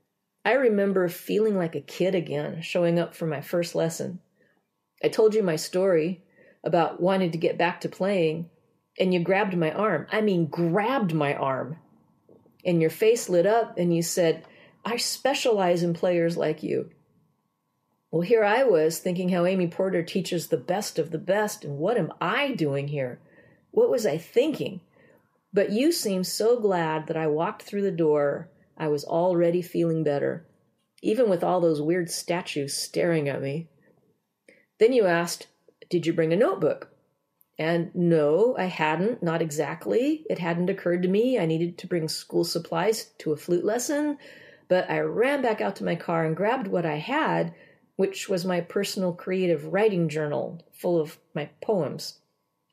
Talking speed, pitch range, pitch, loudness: 170 wpm, 160-195 Hz, 175 Hz, -25 LUFS